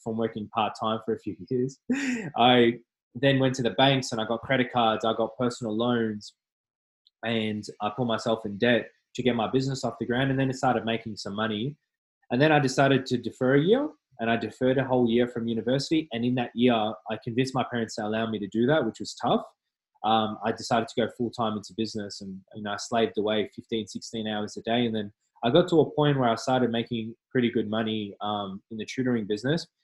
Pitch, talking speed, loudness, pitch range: 115 Hz, 230 wpm, -27 LUFS, 110-130 Hz